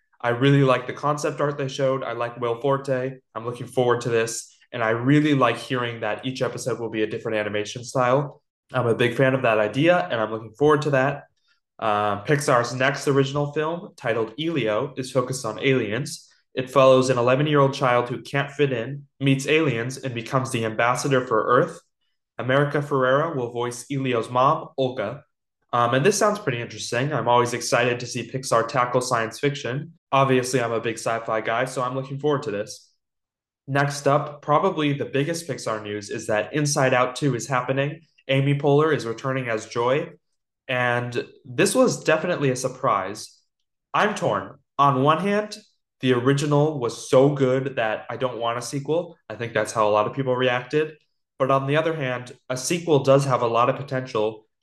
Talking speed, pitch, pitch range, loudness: 190 wpm, 130 Hz, 120-145 Hz, -23 LUFS